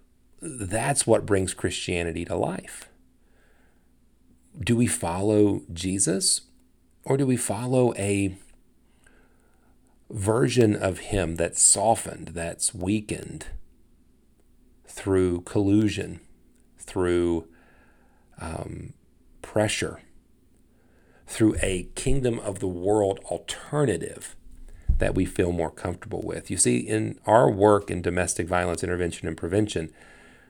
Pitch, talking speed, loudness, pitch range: 95 Hz, 100 wpm, -25 LUFS, 85-105 Hz